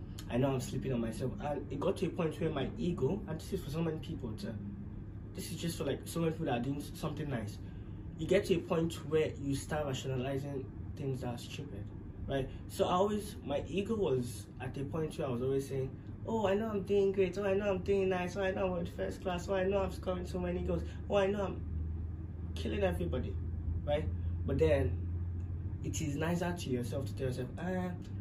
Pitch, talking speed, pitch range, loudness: 115 Hz, 230 wpm, 95-155 Hz, -36 LUFS